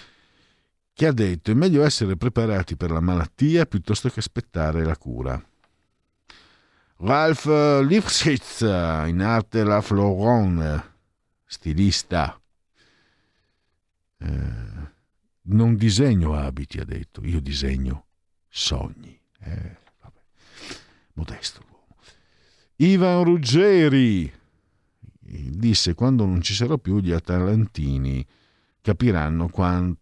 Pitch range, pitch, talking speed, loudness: 85-115 Hz, 95 Hz, 90 wpm, -21 LUFS